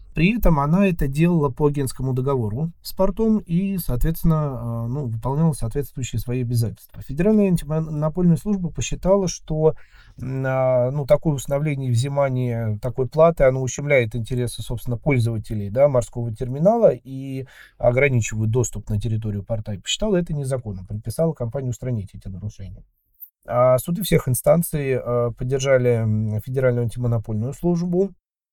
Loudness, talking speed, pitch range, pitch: -22 LUFS, 125 wpm, 120-155 Hz, 130 Hz